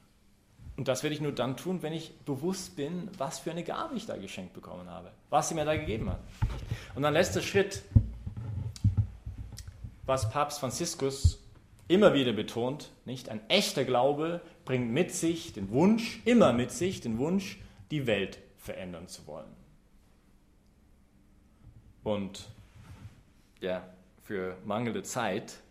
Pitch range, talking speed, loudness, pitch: 100-150 Hz, 140 wpm, -31 LUFS, 115 Hz